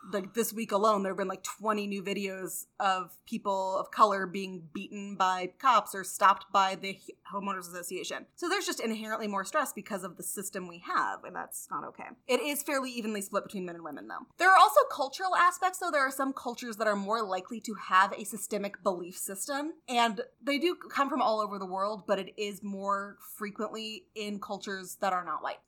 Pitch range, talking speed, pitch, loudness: 195-245 Hz, 215 wpm, 205 Hz, -31 LUFS